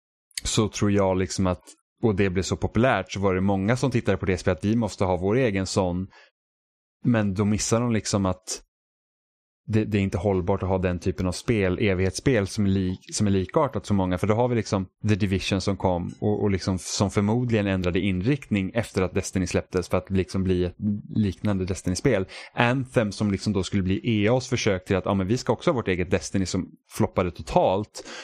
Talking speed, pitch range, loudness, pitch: 215 wpm, 95-110 Hz, -25 LUFS, 100 Hz